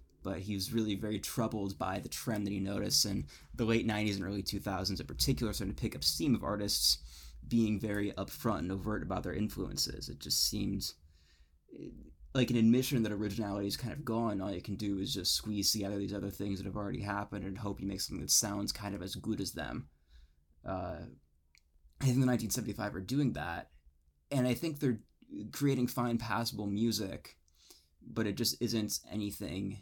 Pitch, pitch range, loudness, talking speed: 100 Hz, 95-115 Hz, -34 LUFS, 195 wpm